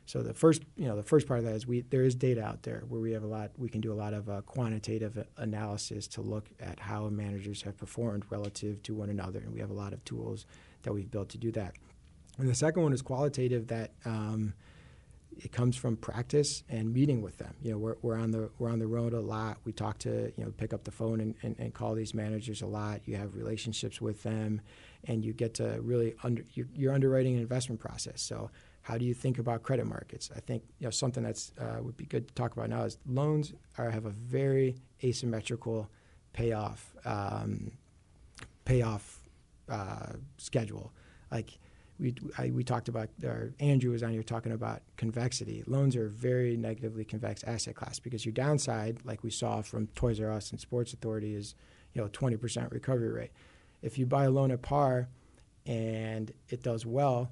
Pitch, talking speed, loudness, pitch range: 115 Hz, 210 wpm, -34 LUFS, 110-125 Hz